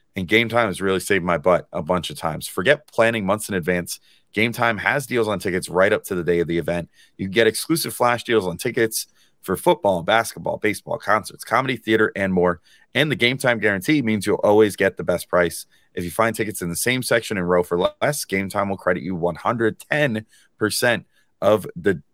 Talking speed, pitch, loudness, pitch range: 220 wpm, 110 Hz, -21 LUFS, 90-115 Hz